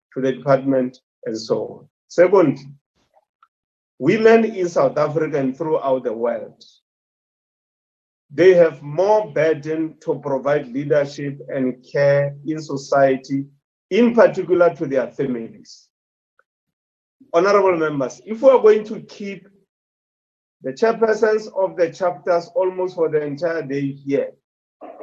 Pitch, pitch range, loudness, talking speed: 155 Hz, 140-185 Hz, -19 LUFS, 120 wpm